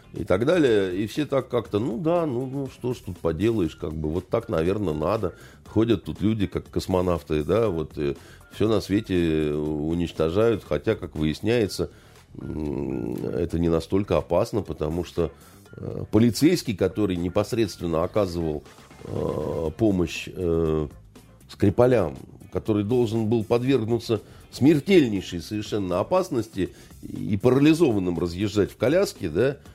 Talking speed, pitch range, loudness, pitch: 120 wpm, 80-115 Hz, -24 LUFS, 95 Hz